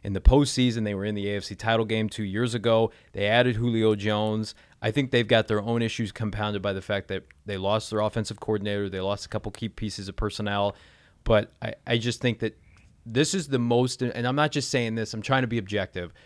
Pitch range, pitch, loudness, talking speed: 100-120 Hz, 110 Hz, -26 LUFS, 235 wpm